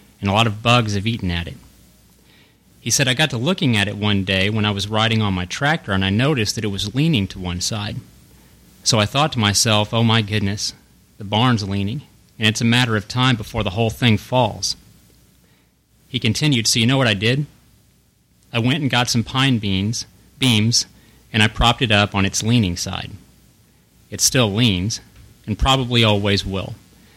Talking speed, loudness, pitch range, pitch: 200 wpm, -18 LUFS, 100-120 Hz, 110 Hz